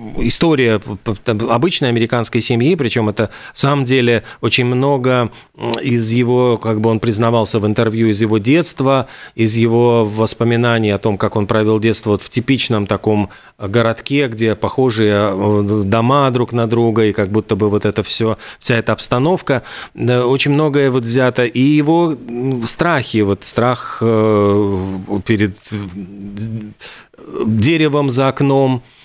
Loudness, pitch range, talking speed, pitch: -15 LUFS, 110-125 Hz, 135 wpm, 115 Hz